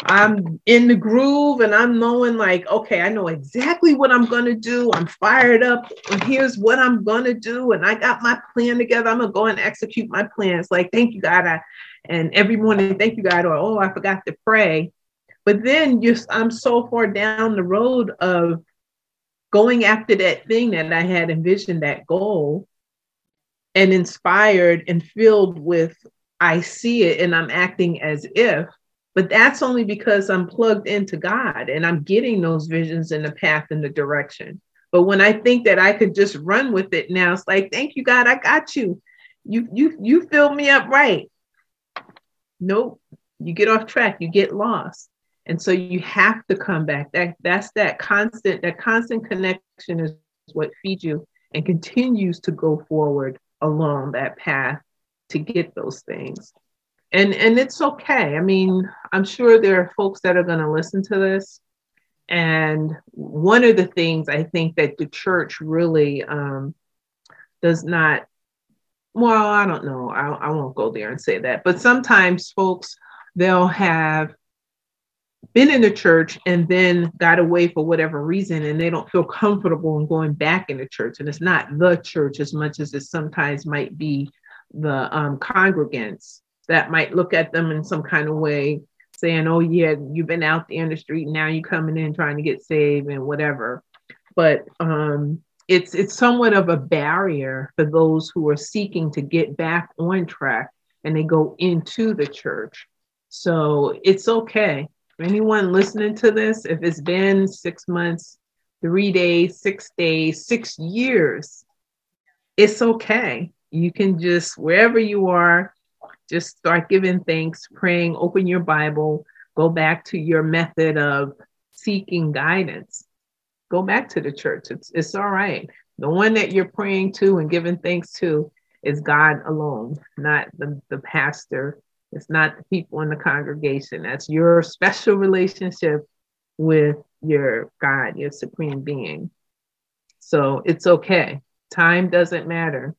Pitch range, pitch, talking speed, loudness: 155-210 Hz, 175 Hz, 170 wpm, -18 LUFS